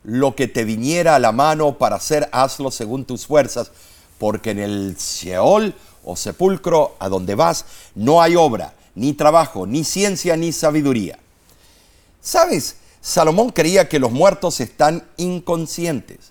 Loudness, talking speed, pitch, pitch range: -17 LUFS, 145 wpm, 135 Hz, 100-165 Hz